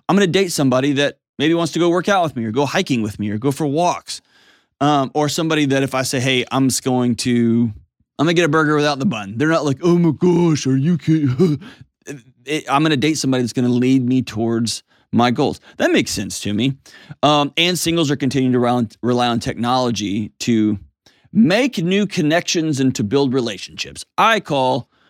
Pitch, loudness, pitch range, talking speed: 140 Hz, -18 LUFS, 120-160 Hz, 215 wpm